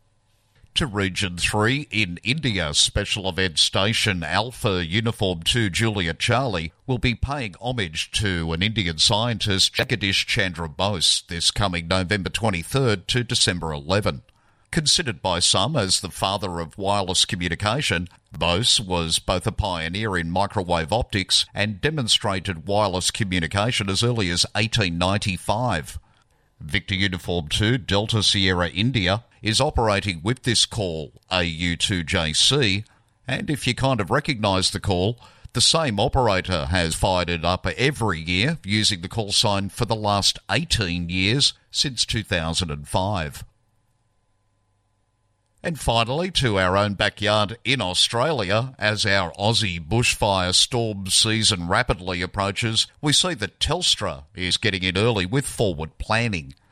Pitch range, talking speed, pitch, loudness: 90-115 Hz, 130 wpm, 100 Hz, -21 LUFS